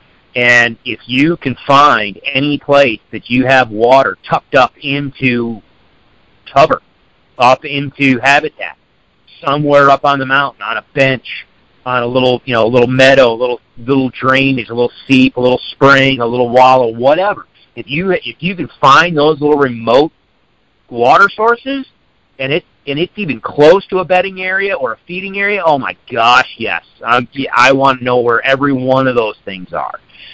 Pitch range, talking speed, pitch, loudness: 125-145 Hz, 175 wpm, 135 Hz, -11 LUFS